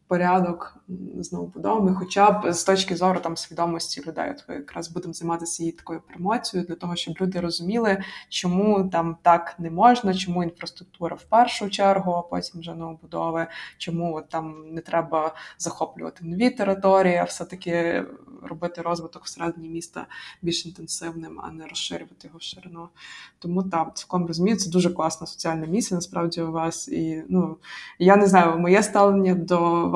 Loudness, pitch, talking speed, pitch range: -23 LUFS, 170 Hz, 160 wpm, 165-190 Hz